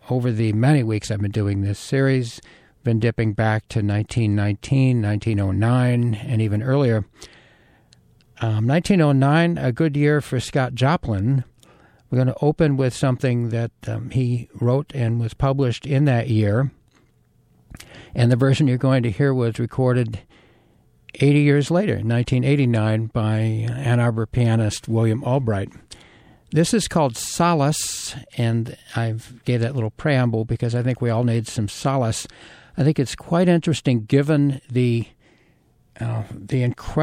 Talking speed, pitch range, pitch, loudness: 145 wpm, 110-135 Hz, 120 Hz, -21 LUFS